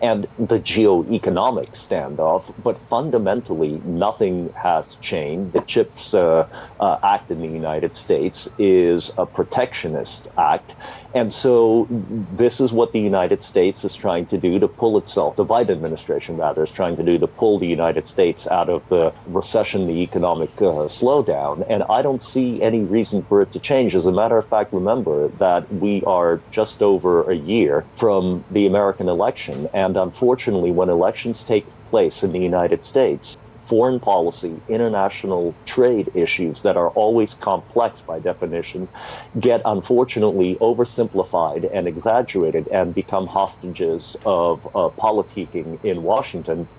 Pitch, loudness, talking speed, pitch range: 100 Hz, -19 LUFS, 155 wpm, 90-115 Hz